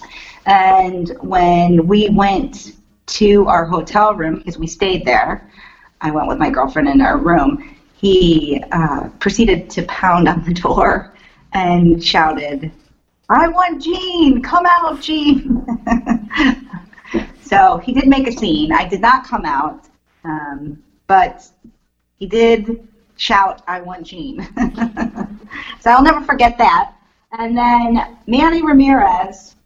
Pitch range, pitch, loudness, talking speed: 180-270 Hz, 220 Hz, -14 LUFS, 130 wpm